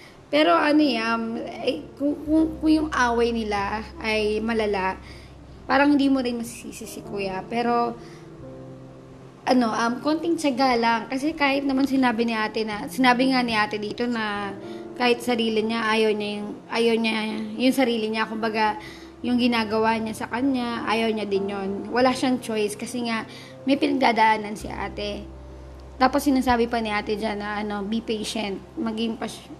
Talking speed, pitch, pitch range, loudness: 160 wpm, 230 Hz, 215-255 Hz, -23 LUFS